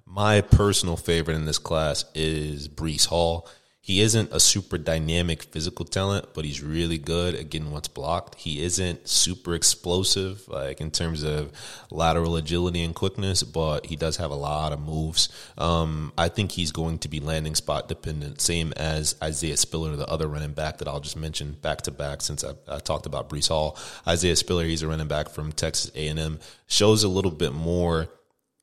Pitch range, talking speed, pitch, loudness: 75-90 Hz, 190 wpm, 80 Hz, -25 LUFS